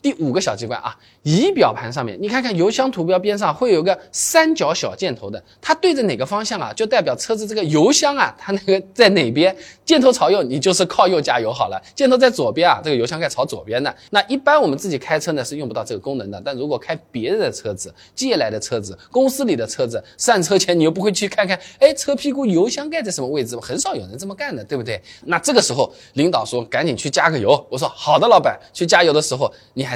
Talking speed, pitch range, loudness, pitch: 370 characters per minute, 195-285 Hz, -18 LUFS, 230 Hz